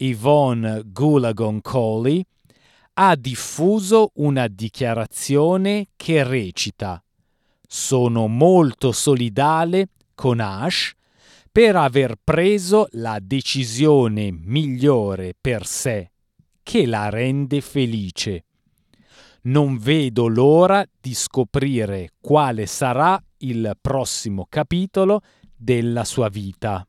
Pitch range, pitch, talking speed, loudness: 110-150 Hz, 130 Hz, 85 wpm, -19 LUFS